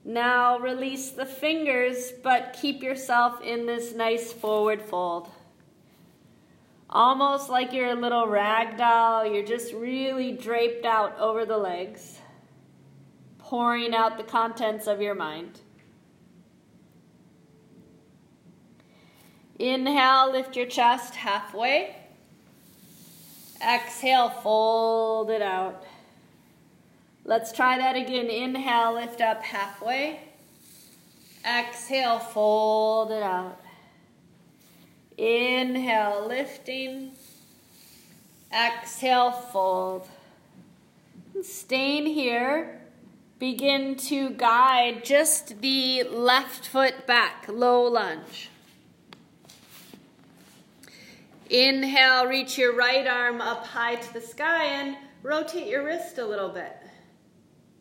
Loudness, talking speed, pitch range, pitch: -24 LUFS, 90 wpm, 225-260 Hz, 240 Hz